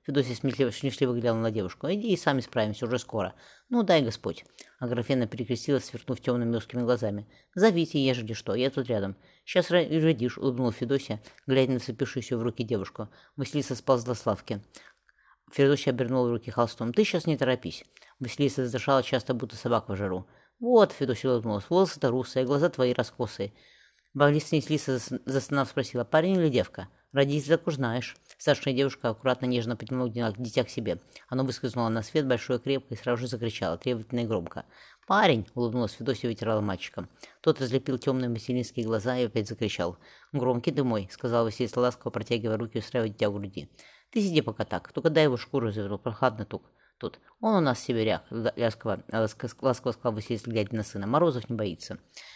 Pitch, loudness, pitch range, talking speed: 125 Hz, -28 LUFS, 115-135 Hz, 170 wpm